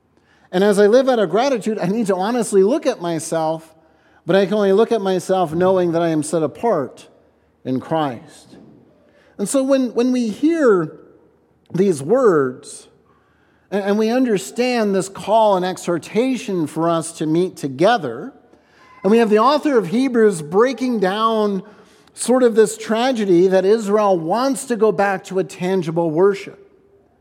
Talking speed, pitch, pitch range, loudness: 160 wpm, 200 Hz, 175-230 Hz, -18 LUFS